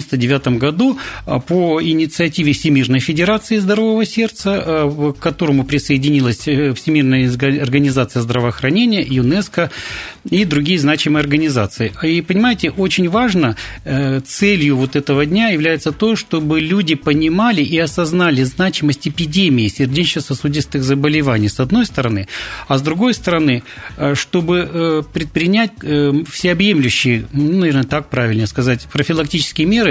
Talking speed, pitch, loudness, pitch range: 110 wpm, 150 Hz, -15 LUFS, 135-175 Hz